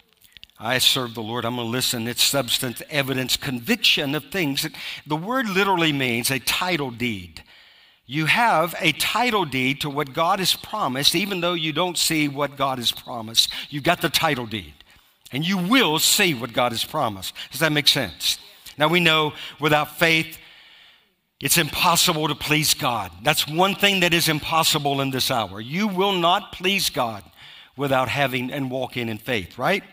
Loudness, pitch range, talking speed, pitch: -21 LUFS, 125-165 Hz, 175 wpm, 145 Hz